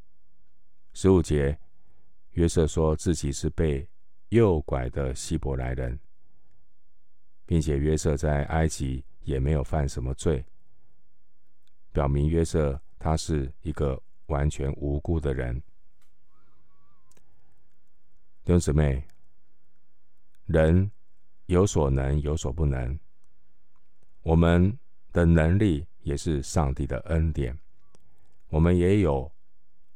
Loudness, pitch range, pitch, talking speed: -26 LUFS, 70-85 Hz, 75 Hz, 145 characters per minute